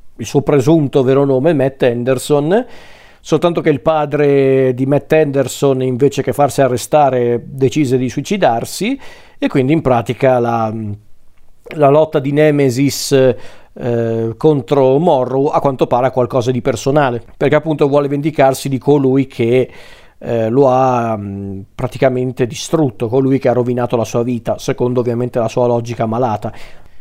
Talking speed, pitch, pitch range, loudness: 145 wpm, 130 Hz, 120-145 Hz, -14 LUFS